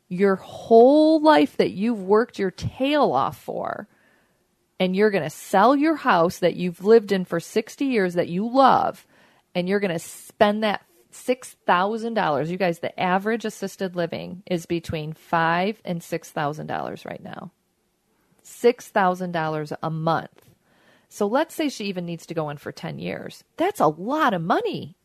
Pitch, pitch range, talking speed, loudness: 190 Hz, 170-230 Hz, 175 wpm, -22 LUFS